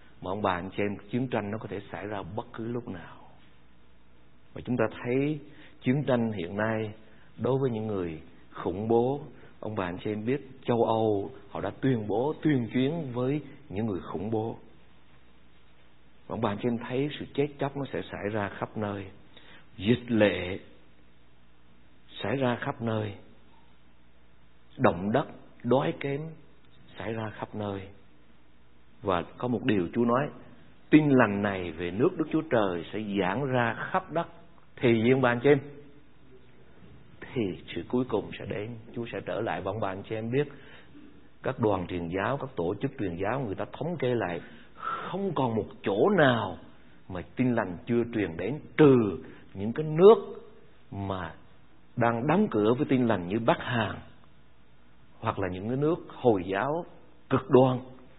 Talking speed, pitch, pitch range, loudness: 170 wpm, 110 Hz, 90-130 Hz, -29 LUFS